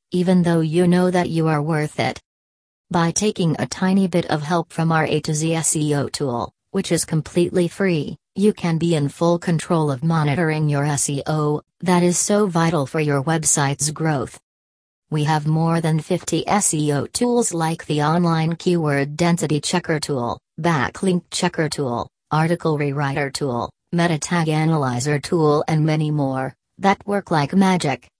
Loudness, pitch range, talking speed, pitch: -20 LUFS, 150-175 Hz, 160 wpm, 160 Hz